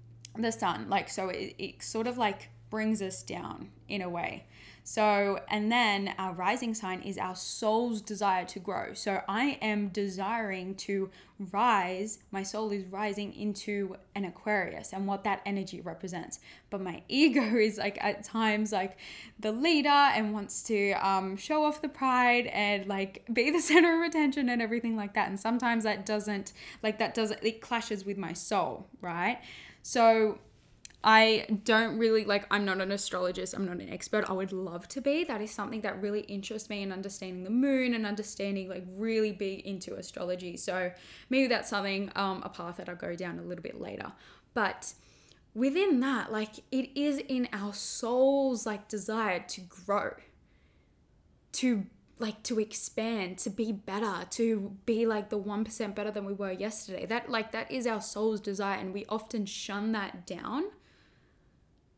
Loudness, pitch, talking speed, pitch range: -31 LUFS, 210 Hz, 175 wpm, 195-230 Hz